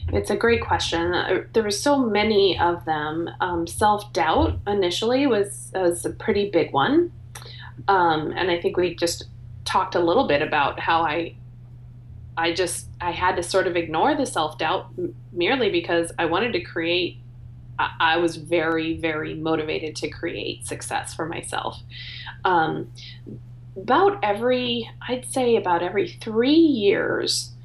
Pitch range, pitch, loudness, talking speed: 120-205 Hz, 170 Hz, -22 LUFS, 150 wpm